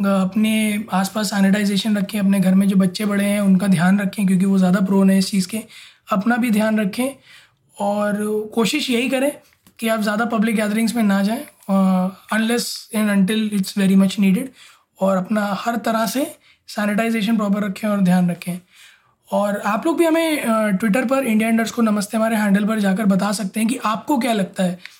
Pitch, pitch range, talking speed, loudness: 210 Hz, 195-225 Hz, 190 wpm, -19 LUFS